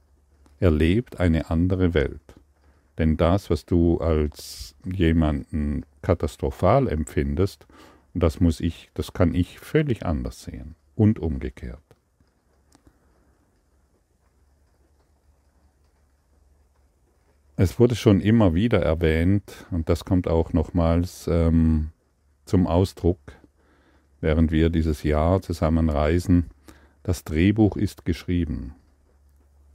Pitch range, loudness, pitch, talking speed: 75-90 Hz, -23 LUFS, 80 Hz, 95 wpm